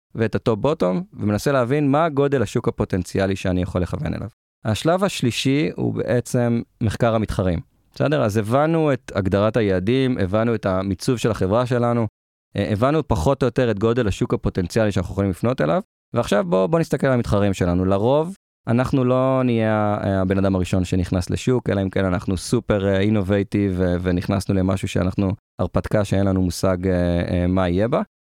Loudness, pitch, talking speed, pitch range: -21 LUFS, 105 Hz, 155 wpm, 95-125 Hz